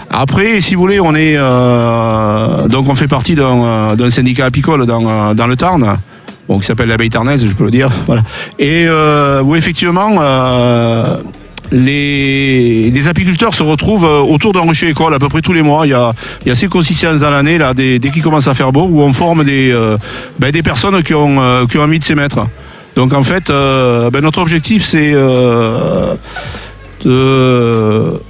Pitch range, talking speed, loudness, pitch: 120-160 Hz, 205 wpm, -10 LUFS, 140 Hz